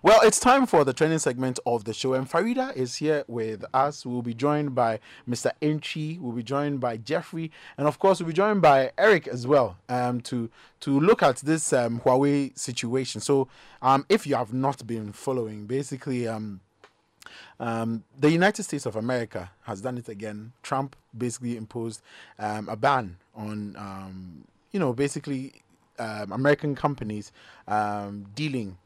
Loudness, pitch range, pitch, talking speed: -25 LUFS, 110-145 Hz, 130 Hz, 170 wpm